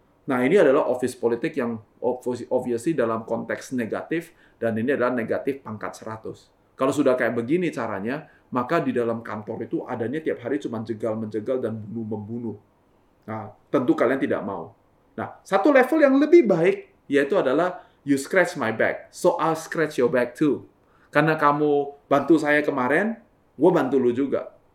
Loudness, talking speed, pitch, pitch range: -23 LUFS, 160 wpm, 125 Hz, 115-150 Hz